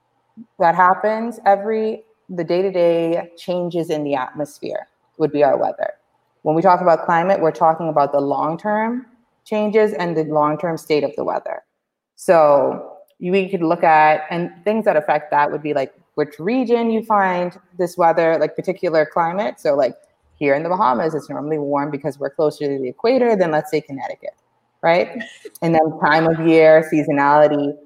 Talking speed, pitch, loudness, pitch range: 175 wpm, 165 Hz, -18 LUFS, 150-195 Hz